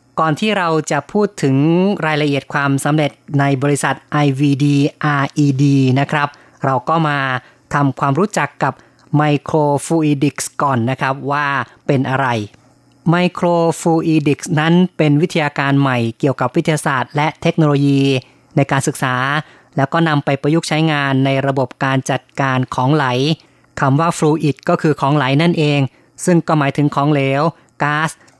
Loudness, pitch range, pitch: -16 LUFS, 135-155 Hz, 145 Hz